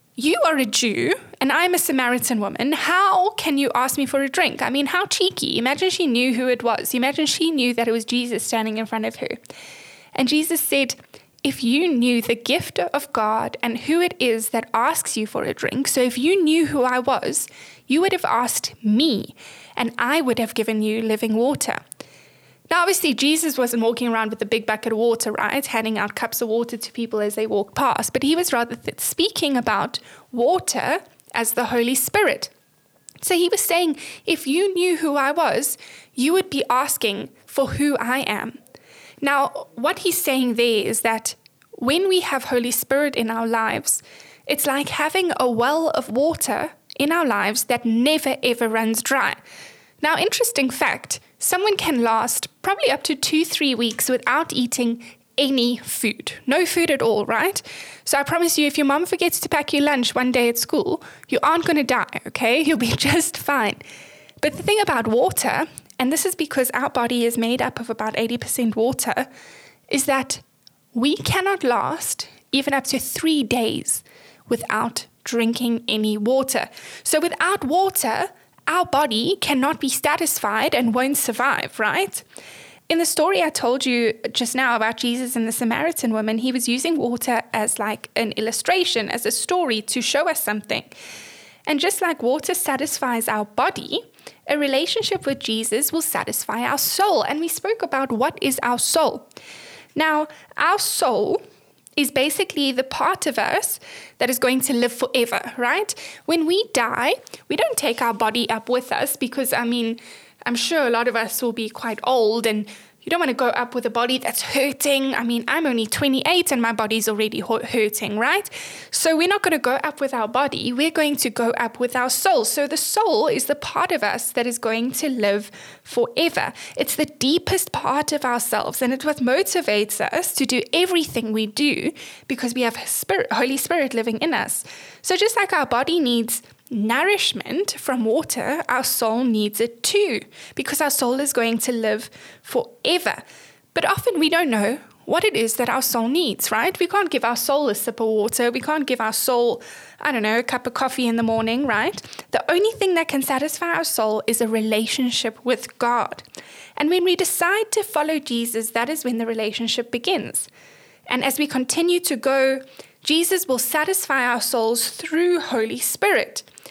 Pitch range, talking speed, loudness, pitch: 235-315 Hz, 190 wpm, -21 LUFS, 265 Hz